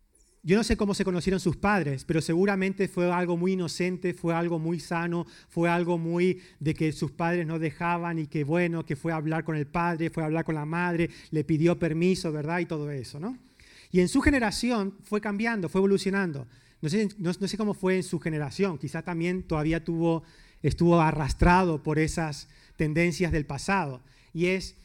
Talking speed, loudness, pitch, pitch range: 200 wpm, -27 LUFS, 170 Hz, 160-185 Hz